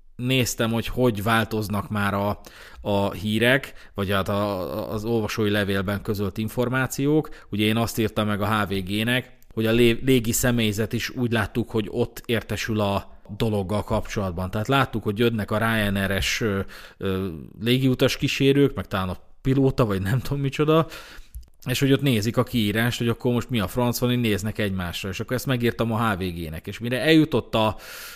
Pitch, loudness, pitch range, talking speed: 110 Hz, -24 LUFS, 100-125 Hz, 165 wpm